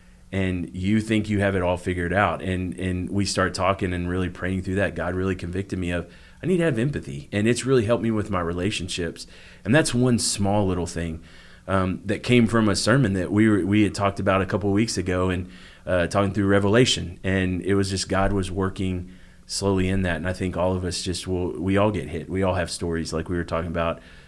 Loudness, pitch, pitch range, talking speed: -24 LUFS, 95 Hz, 90-100 Hz, 240 wpm